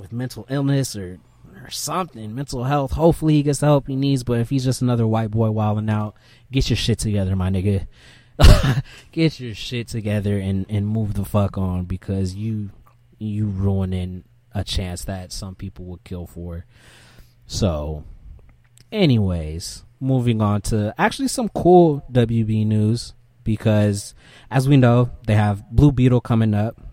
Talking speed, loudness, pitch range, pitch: 160 wpm, -20 LUFS, 100-125 Hz, 110 Hz